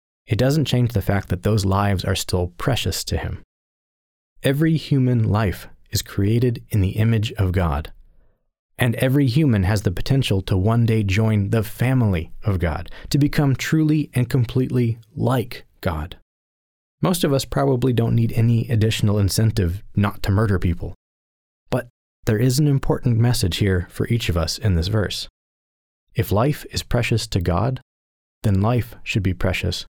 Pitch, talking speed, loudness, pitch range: 110 Hz, 165 wpm, -21 LUFS, 95-125 Hz